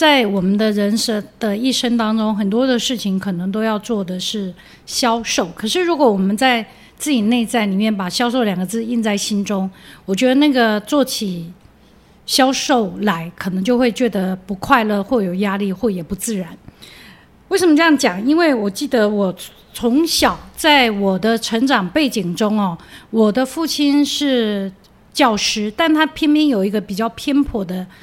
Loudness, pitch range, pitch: -17 LUFS, 200-260 Hz, 225 Hz